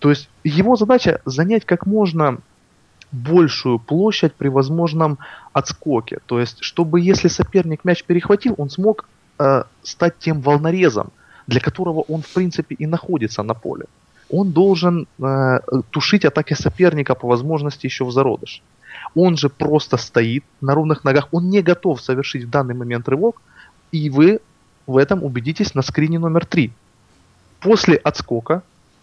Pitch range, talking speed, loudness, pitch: 135-175 Hz, 145 wpm, -18 LUFS, 155 Hz